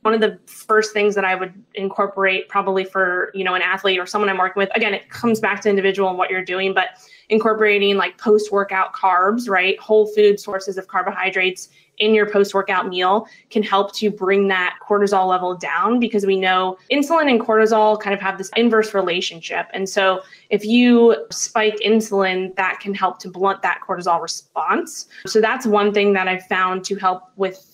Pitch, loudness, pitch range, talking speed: 195 Hz, -18 LUFS, 185-210 Hz, 195 wpm